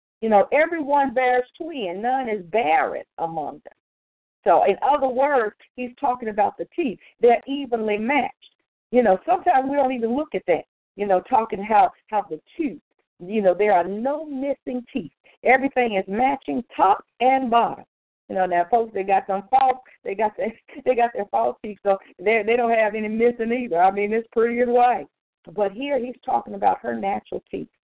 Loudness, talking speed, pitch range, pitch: -22 LUFS, 195 wpm, 210-265 Hz, 240 Hz